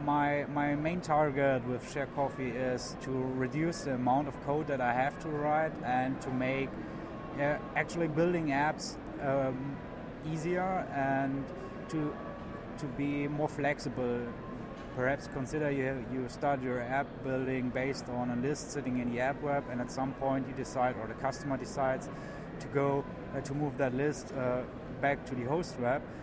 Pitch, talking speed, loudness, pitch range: 135 Hz, 170 wpm, -34 LUFS, 130-145 Hz